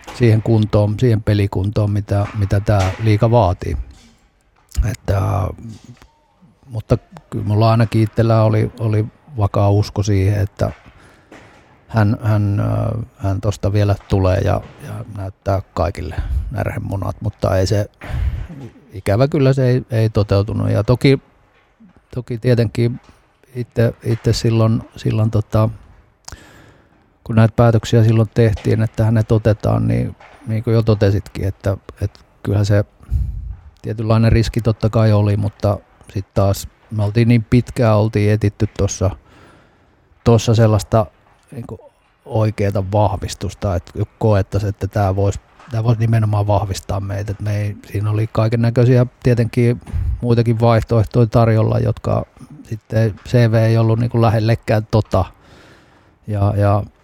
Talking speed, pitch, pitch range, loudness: 120 wpm, 110 Hz, 100-115 Hz, -17 LUFS